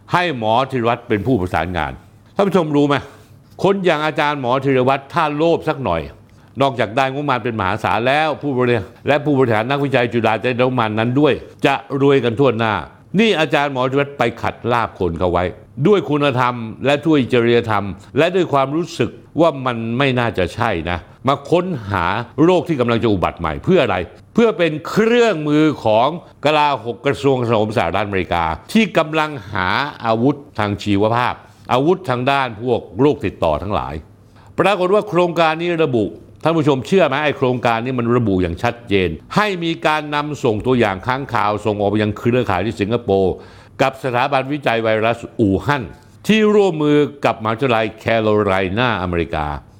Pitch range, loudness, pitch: 110-145 Hz, -17 LUFS, 125 Hz